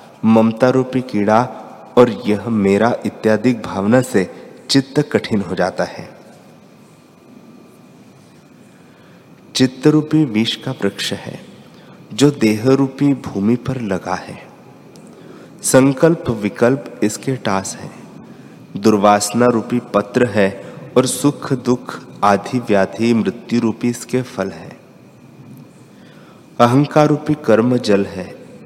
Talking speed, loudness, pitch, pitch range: 105 wpm, -16 LUFS, 120 Hz, 110-135 Hz